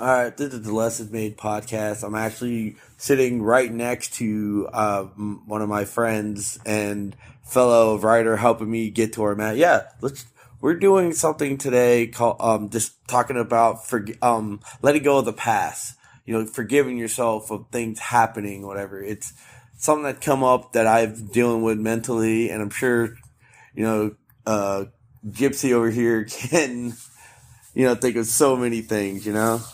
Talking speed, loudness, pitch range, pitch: 170 wpm, -22 LUFS, 110-125 Hz, 115 Hz